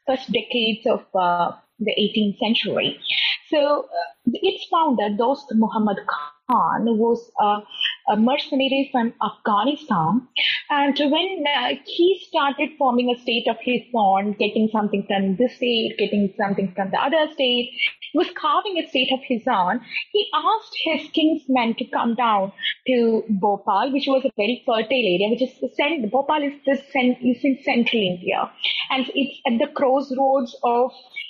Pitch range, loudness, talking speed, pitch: 220-280 Hz, -21 LUFS, 160 wpm, 250 Hz